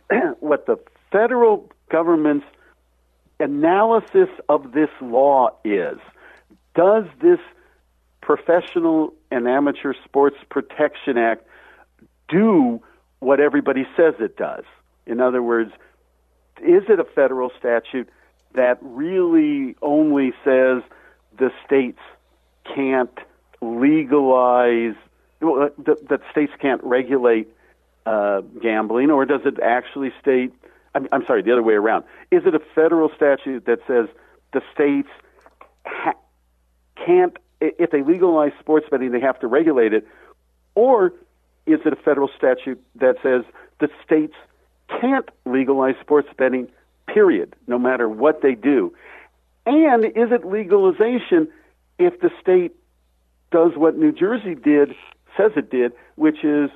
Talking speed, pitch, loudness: 120 wpm, 145 Hz, -19 LUFS